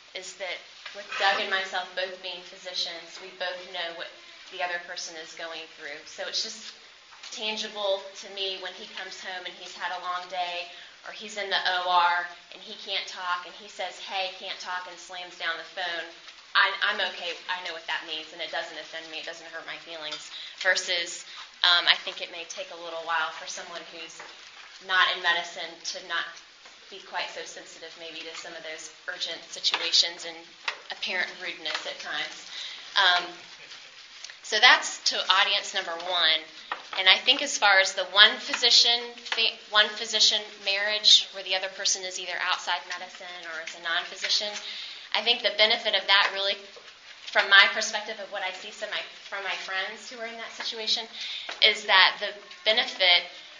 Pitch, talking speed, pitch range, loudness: 185 Hz, 185 wpm, 170-200 Hz, -25 LUFS